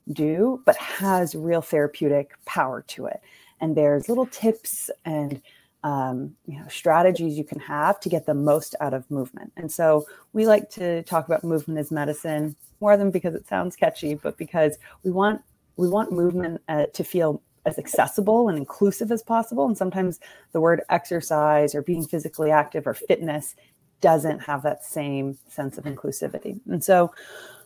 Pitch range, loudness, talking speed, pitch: 150-185 Hz, -24 LUFS, 170 wpm, 160 Hz